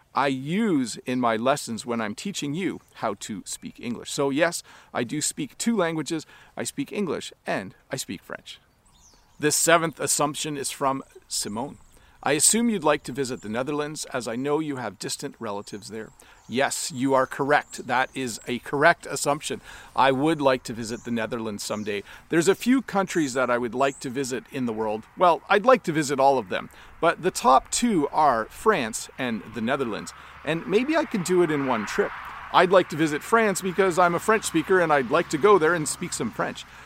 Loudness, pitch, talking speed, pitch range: -24 LUFS, 150 Hz, 205 wpm, 130-185 Hz